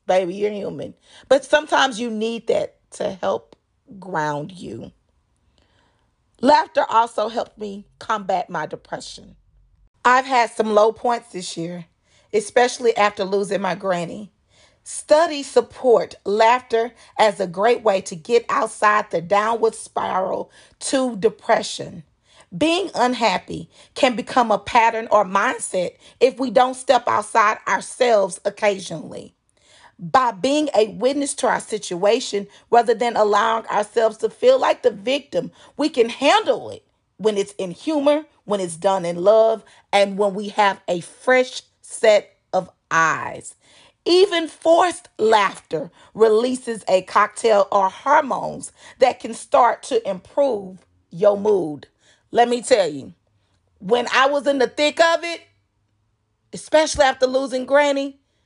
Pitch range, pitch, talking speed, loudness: 195-270 Hz, 225 Hz, 135 wpm, -19 LUFS